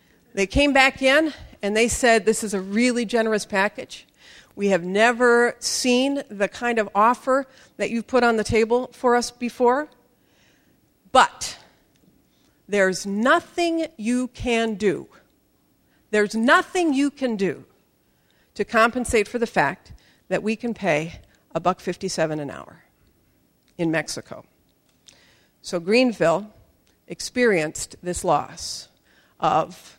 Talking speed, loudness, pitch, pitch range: 125 wpm, -22 LUFS, 230 Hz, 200-250 Hz